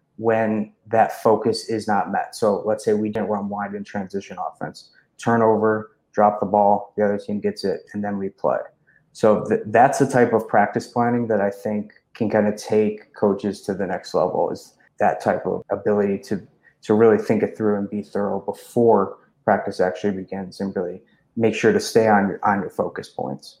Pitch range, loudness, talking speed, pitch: 100-110 Hz, -21 LUFS, 200 wpm, 105 Hz